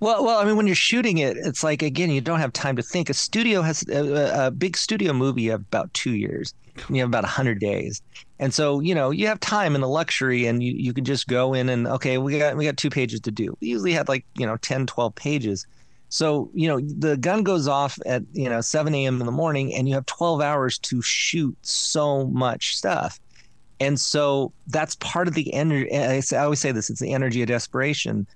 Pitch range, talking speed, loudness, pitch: 130-160 Hz, 235 wpm, -23 LUFS, 140 Hz